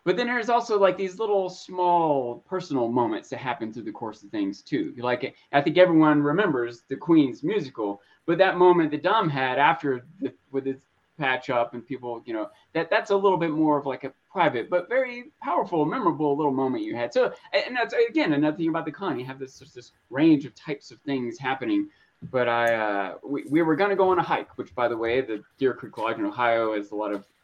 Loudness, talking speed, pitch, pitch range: -25 LUFS, 230 wpm, 150 Hz, 130-190 Hz